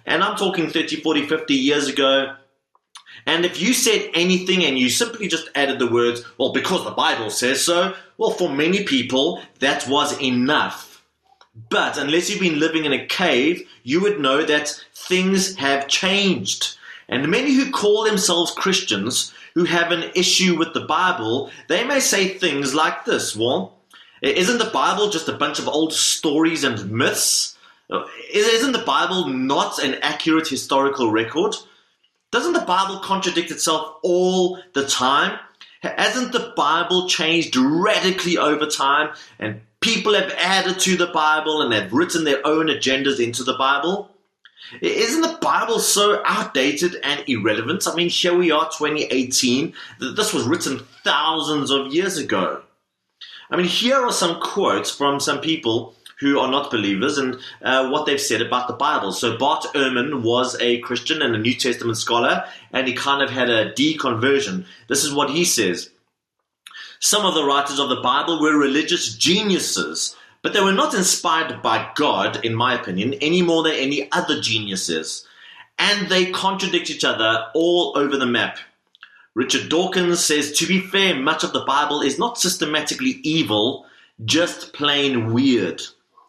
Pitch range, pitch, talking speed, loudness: 140-185 Hz, 160 Hz, 165 wpm, -19 LUFS